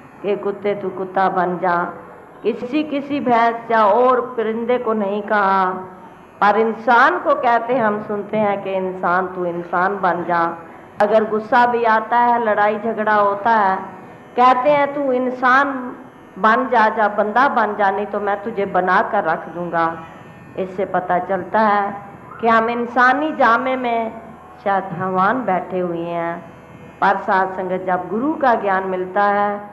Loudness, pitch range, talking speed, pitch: -18 LUFS, 185-230 Hz, 155 wpm, 205 Hz